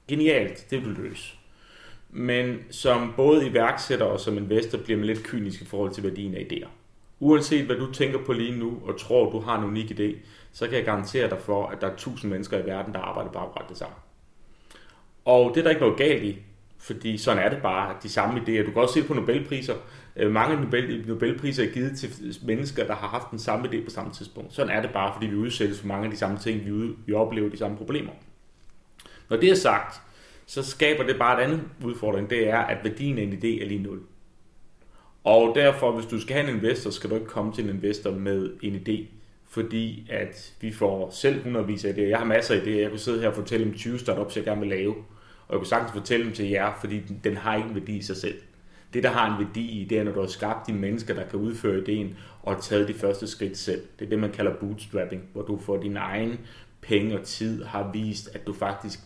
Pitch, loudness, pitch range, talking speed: 110 Hz, -26 LUFS, 100-120 Hz, 240 wpm